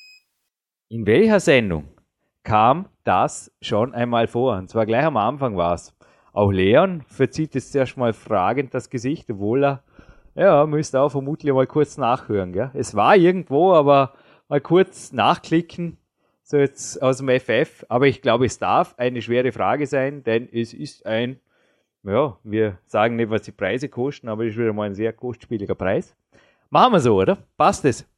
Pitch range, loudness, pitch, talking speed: 110-140 Hz, -20 LUFS, 125 Hz, 175 wpm